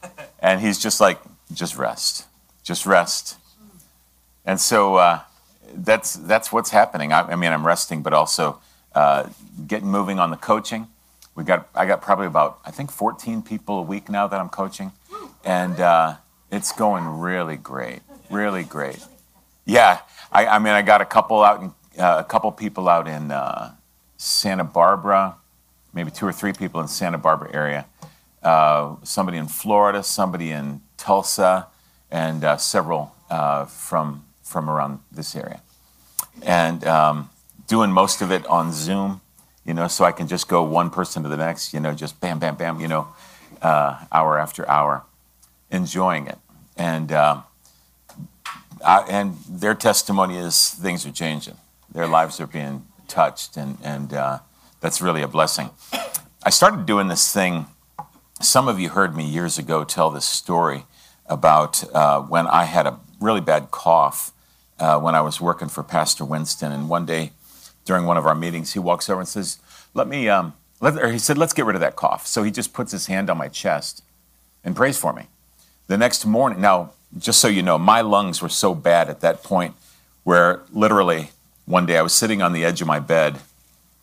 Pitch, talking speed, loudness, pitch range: 80 Hz, 180 wpm, -20 LUFS, 75-95 Hz